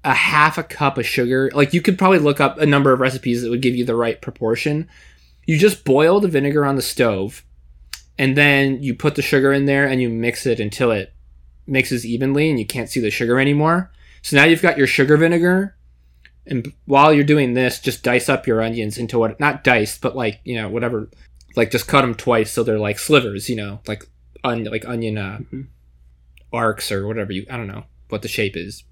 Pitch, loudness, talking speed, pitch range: 125 Hz, -17 LUFS, 220 wpm, 110-140 Hz